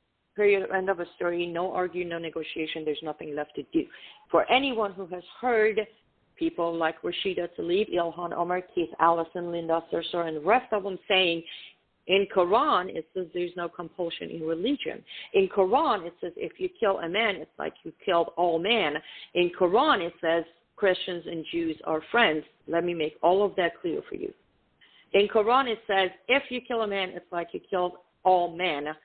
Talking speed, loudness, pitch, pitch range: 190 wpm, -27 LUFS, 180 Hz, 170-215 Hz